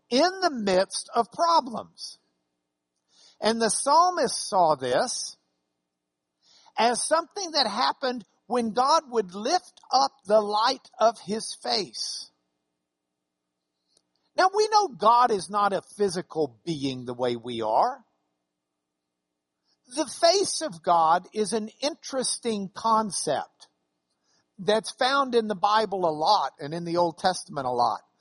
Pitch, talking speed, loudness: 205 Hz, 125 wpm, -25 LUFS